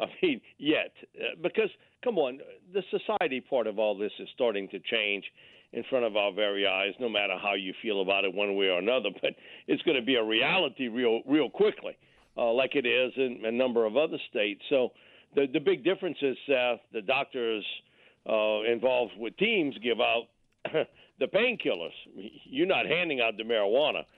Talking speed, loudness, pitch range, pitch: 190 wpm, -29 LUFS, 105-135 Hz, 115 Hz